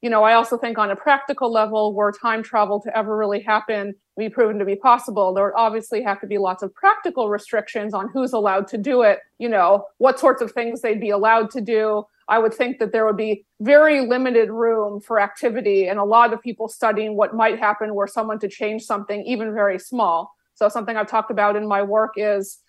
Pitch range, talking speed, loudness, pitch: 205-235 Hz, 225 wpm, -20 LUFS, 220 Hz